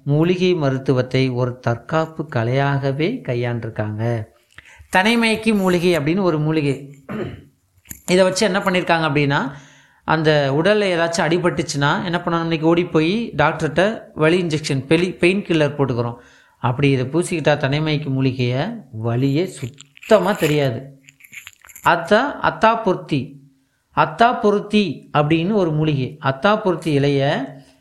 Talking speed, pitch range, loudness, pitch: 110 wpm, 135-180 Hz, -19 LUFS, 155 Hz